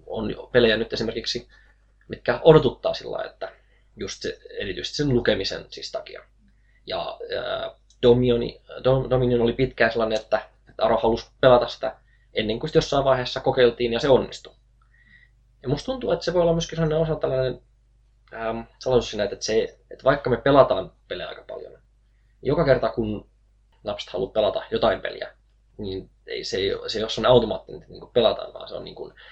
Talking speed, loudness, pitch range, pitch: 170 wpm, -23 LUFS, 115-160 Hz, 125 Hz